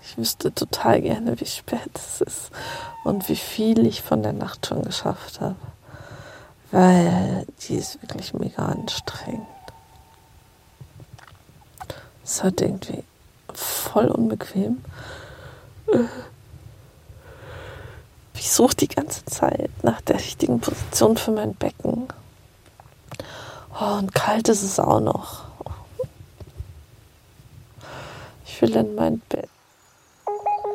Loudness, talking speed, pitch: -23 LUFS, 105 wpm, 210 Hz